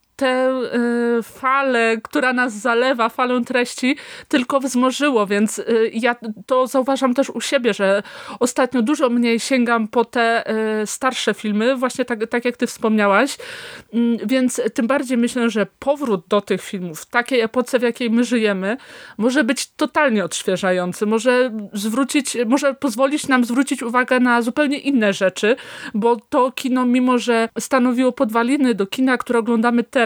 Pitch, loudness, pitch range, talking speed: 245 Hz, -19 LUFS, 225-265 Hz, 145 wpm